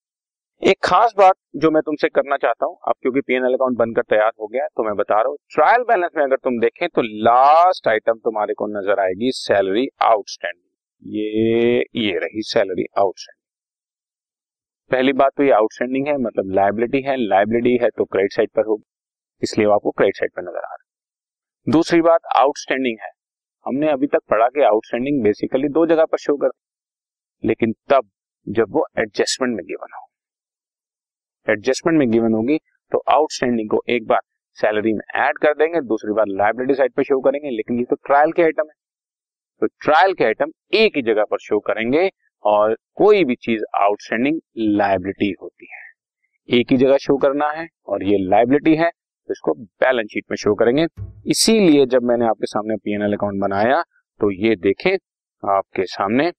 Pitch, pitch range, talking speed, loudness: 130 Hz, 110-160 Hz, 180 wpm, -18 LUFS